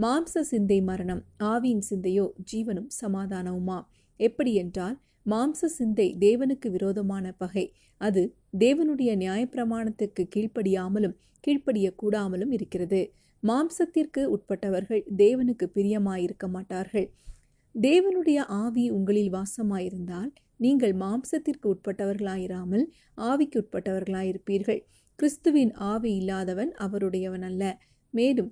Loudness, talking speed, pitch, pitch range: -27 LUFS, 85 wpm, 205 Hz, 190-245 Hz